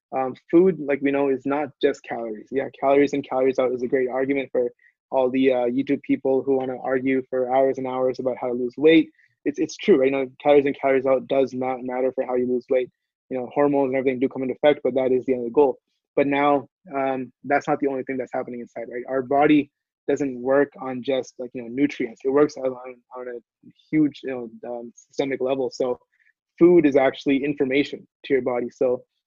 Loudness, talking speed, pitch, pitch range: -22 LUFS, 230 wpm, 135 Hz, 130-140 Hz